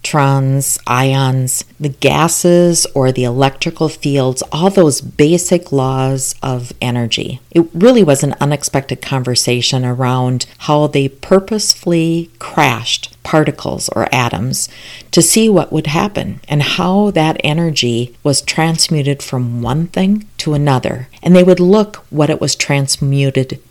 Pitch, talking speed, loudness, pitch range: 145 Hz, 130 wpm, -13 LUFS, 130-170 Hz